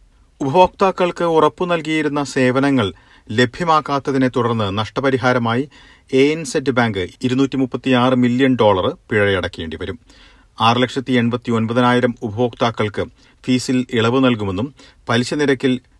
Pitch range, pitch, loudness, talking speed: 120-140 Hz, 130 Hz, -17 LUFS, 80 wpm